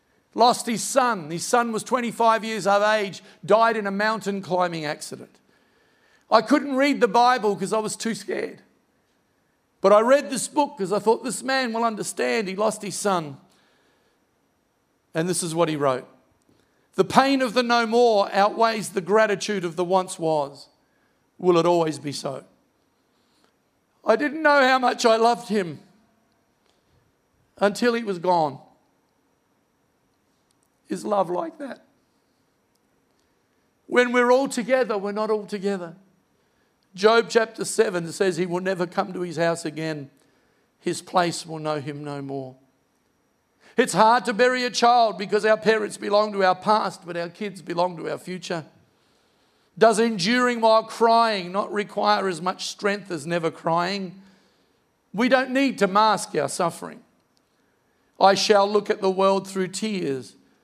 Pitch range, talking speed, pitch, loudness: 180-230 Hz, 155 wpm, 205 Hz, -22 LUFS